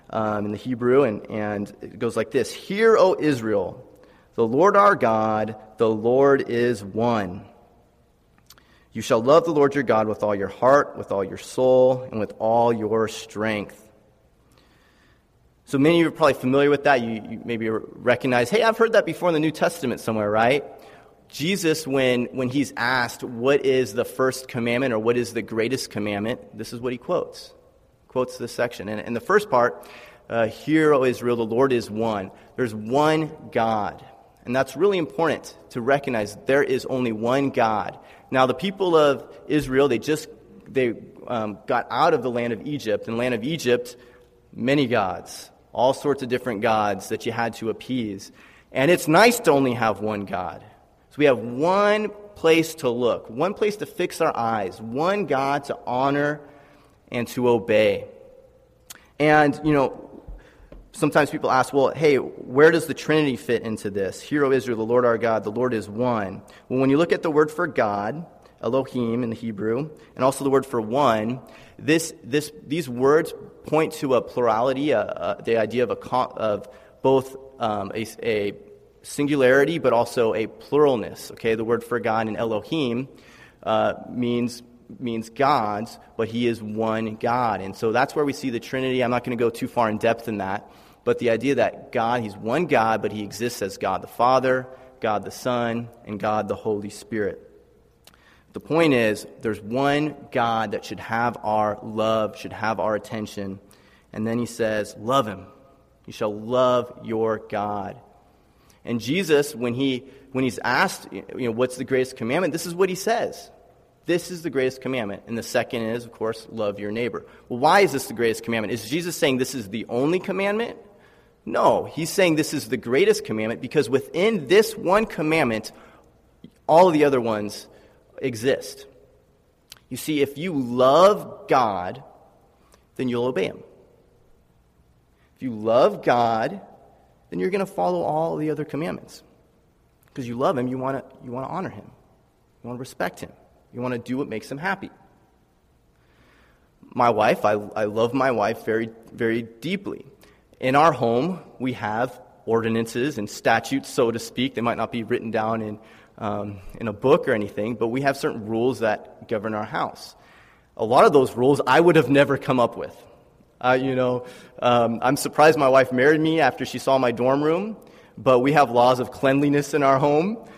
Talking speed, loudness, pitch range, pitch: 185 wpm, -22 LUFS, 110-145 Hz, 125 Hz